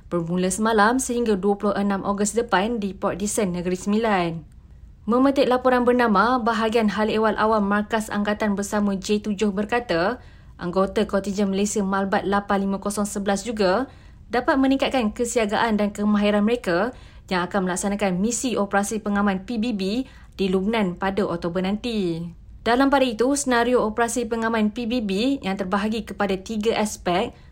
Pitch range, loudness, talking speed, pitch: 195-230 Hz, -22 LUFS, 130 wpm, 210 Hz